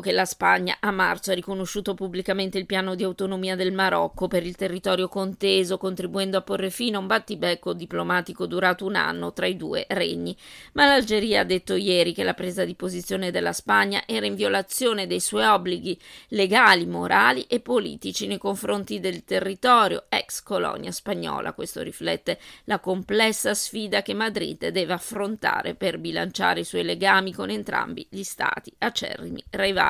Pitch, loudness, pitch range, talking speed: 190 Hz, -24 LUFS, 180-200 Hz, 165 wpm